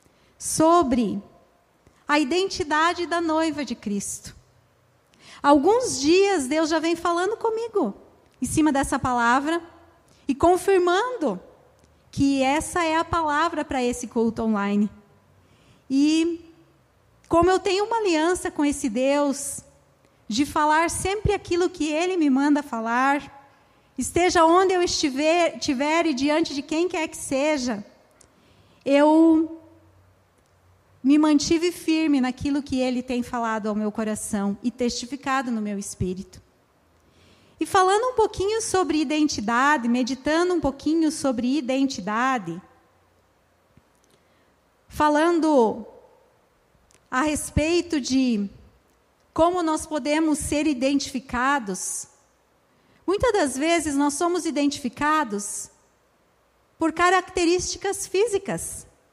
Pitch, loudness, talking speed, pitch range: 300 Hz, -23 LUFS, 105 wpm, 260-340 Hz